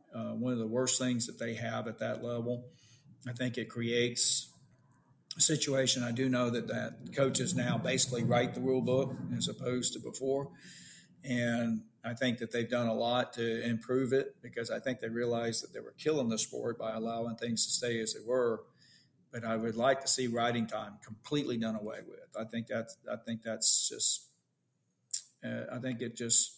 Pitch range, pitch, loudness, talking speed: 115-125 Hz, 120 Hz, -32 LUFS, 200 wpm